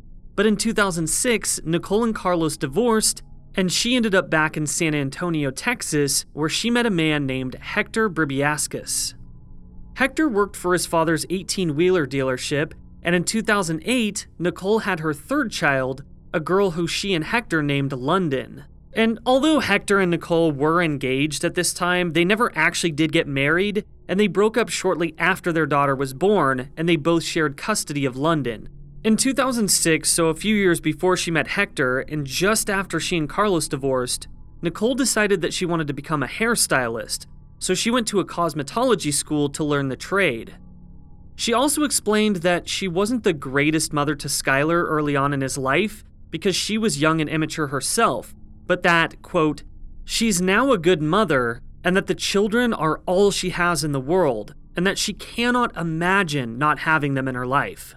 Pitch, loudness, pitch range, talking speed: 170 Hz, -21 LUFS, 150-200 Hz, 175 wpm